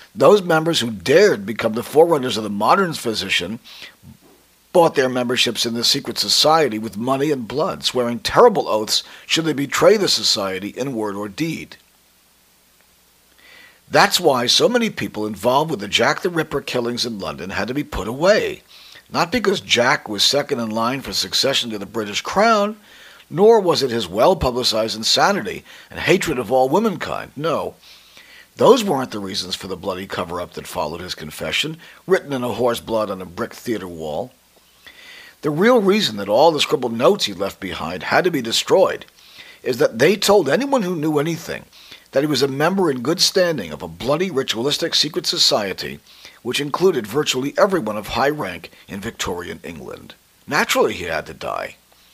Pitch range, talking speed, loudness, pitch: 110-185 Hz, 175 wpm, -18 LUFS, 135 Hz